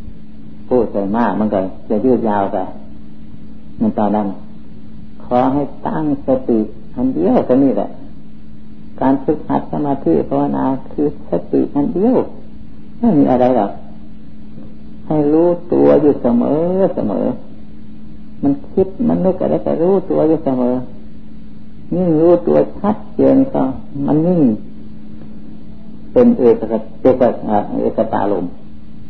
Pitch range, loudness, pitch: 105-170 Hz, -16 LUFS, 130 Hz